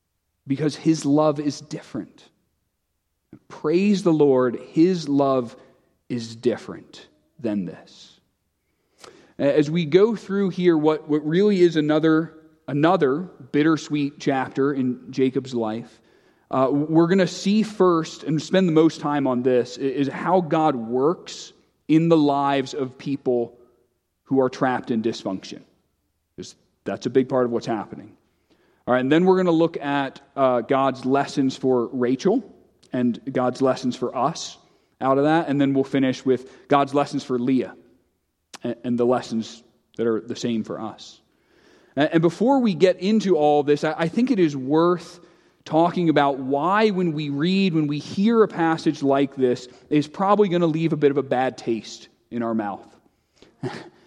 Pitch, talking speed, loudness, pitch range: 140 Hz, 165 wpm, -21 LUFS, 125-165 Hz